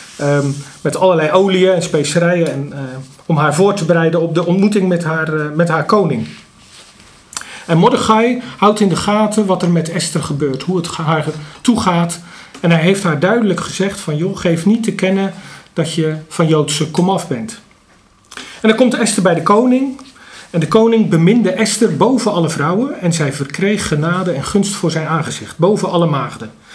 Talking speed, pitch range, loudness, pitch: 185 wpm, 160-200 Hz, -14 LUFS, 175 Hz